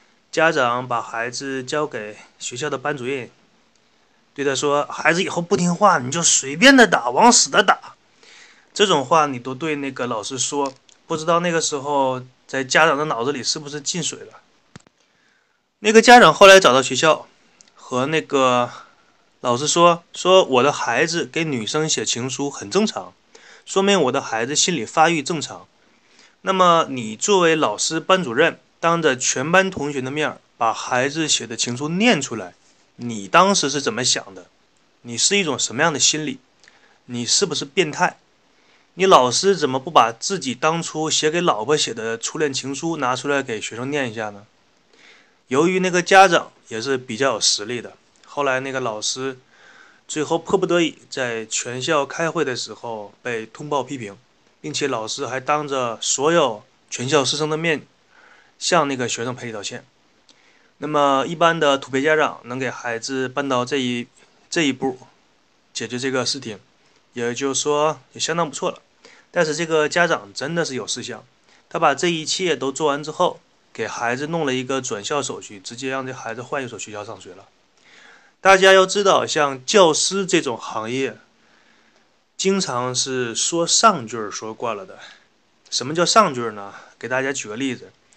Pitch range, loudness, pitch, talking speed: 125-170 Hz, -19 LUFS, 145 Hz, 250 characters per minute